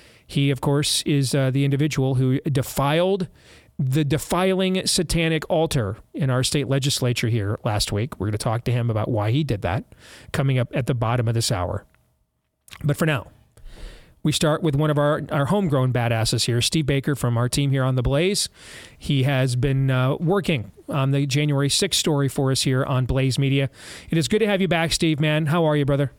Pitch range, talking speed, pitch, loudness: 125-155 Hz, 205 wpm, 140 Hz, -22 LUFS